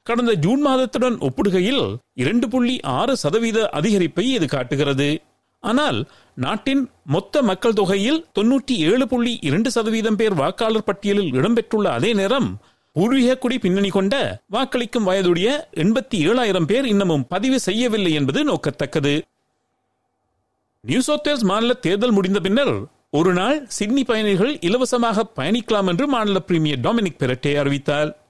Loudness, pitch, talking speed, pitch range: -19 LUFS, 215 Hz, 110 wpm, 180-250 Hz